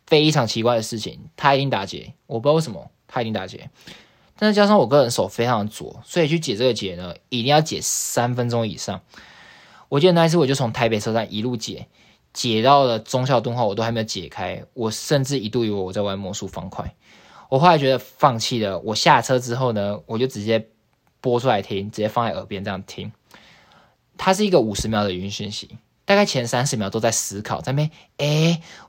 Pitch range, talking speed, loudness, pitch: 105-140 Hz, 315 characters per minute, -21 LUFS, 120 Hz